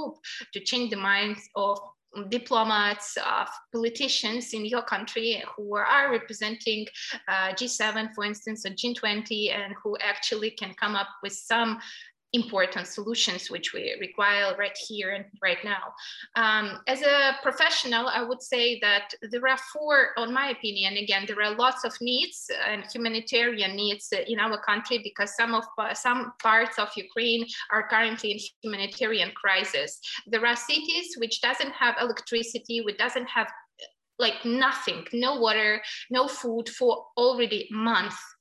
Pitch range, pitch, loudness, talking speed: 210-245 Hz, 225 Hz, -26 LUFS, 150 wpm